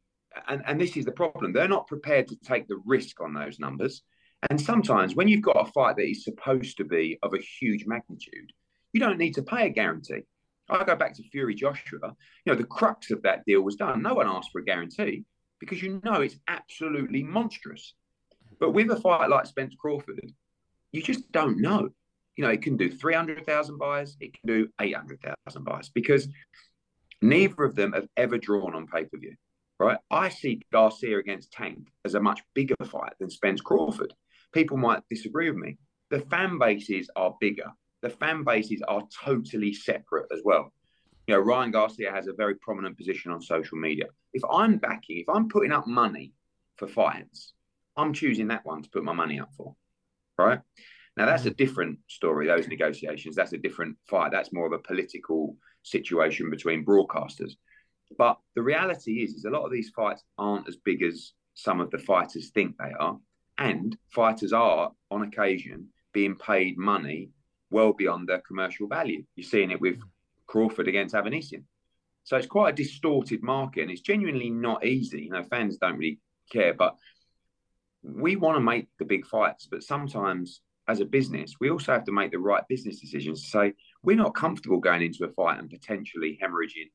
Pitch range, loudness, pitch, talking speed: 100-155 Hz, -27 LUFS, 115 Hz, 195 wpm